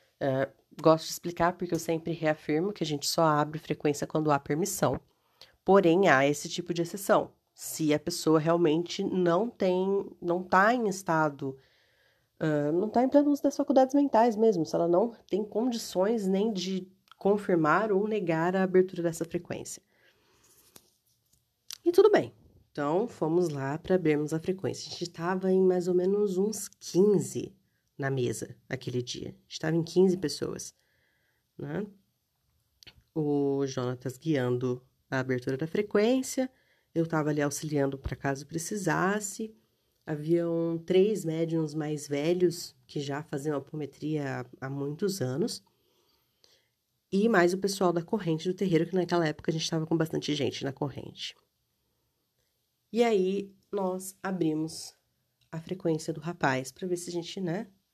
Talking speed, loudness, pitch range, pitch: 155 wpm, -29 LUFS, 150-190 Hz, 170 Hz